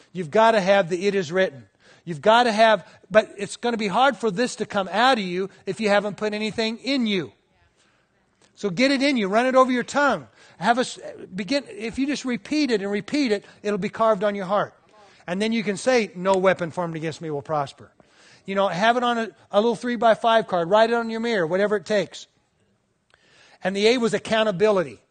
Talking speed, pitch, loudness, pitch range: 230 wpm, 210 Hz, -22 LUFS, 190-230 Hz